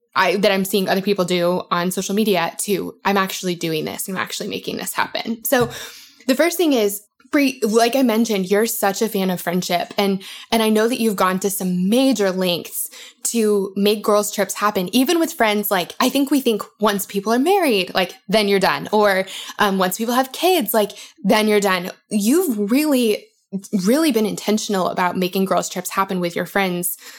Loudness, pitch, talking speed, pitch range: -19 LUFS, 210 Hz, 195 wpm, 190-230 Hz